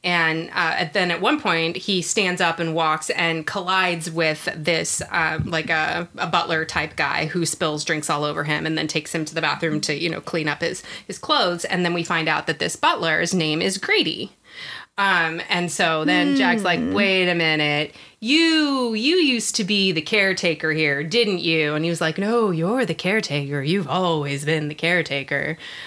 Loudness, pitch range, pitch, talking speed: -21 LUFS, 160-190 Hz, 170 Hz, 200 wpm